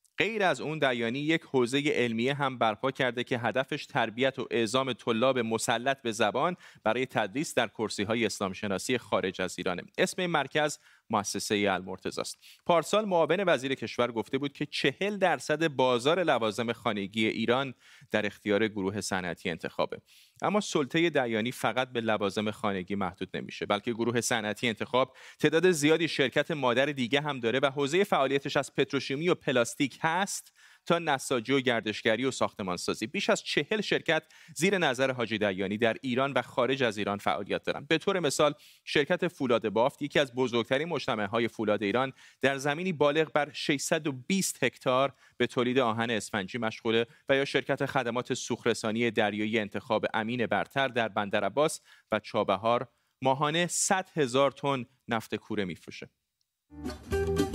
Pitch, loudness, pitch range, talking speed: 130 Hz, -29 LUFS, 115-150 Hz, 155 wpm